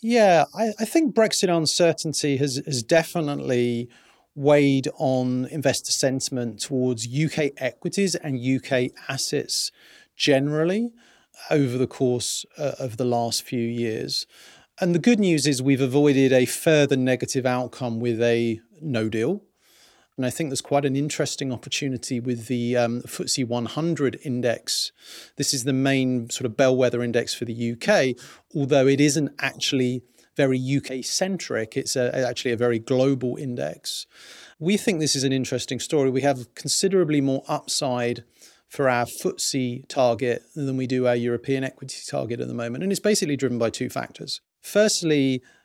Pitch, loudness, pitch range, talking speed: 135 Hz, -23 LUFS, 125-150 Hz, 155 wpm